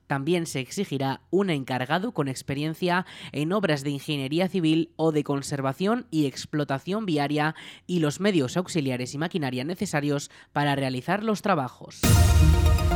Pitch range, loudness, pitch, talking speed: 135-175 Hz, -26 LUFS, 150 Hz, 135 wpm